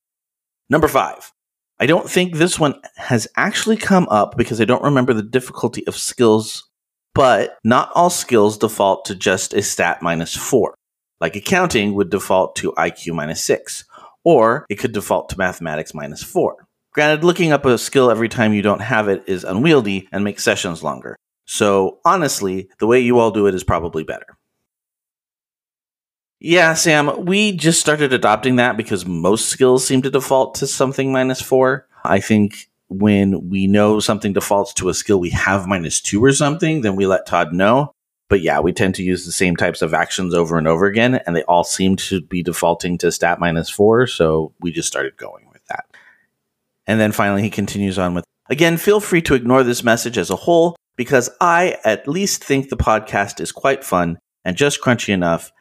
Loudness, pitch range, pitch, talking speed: -17 LUFS, 95-135 Hz, 110 Hz, 190 wpm